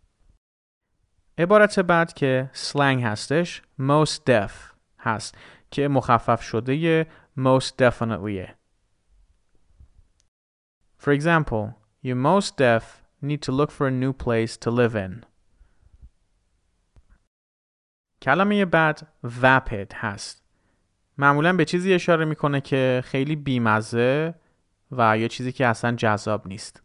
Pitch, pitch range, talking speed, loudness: 120 Hz, 95-145 Hz, 95 wpm, -22 LUFS